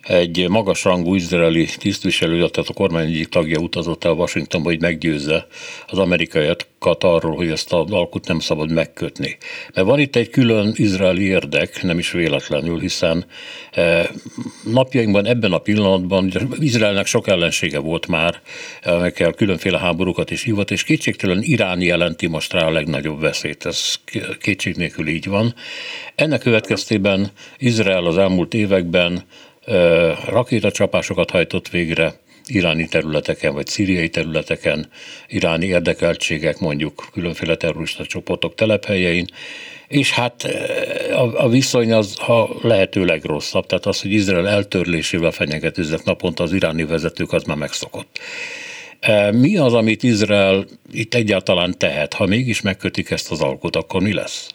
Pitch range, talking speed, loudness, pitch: 85-115 Hz, 135 wpm, -18 LUFS, 95 Hz